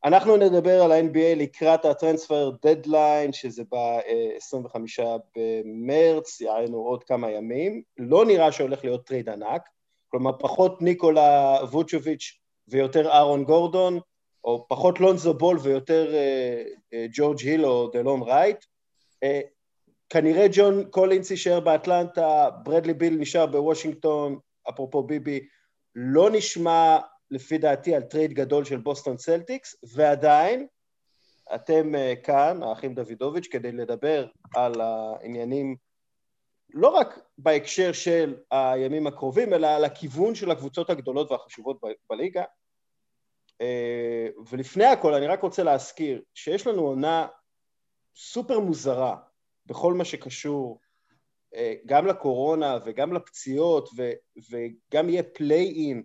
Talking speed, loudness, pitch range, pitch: 115 wpm, -23 LUFS, 130-170 Hz, 150 Hz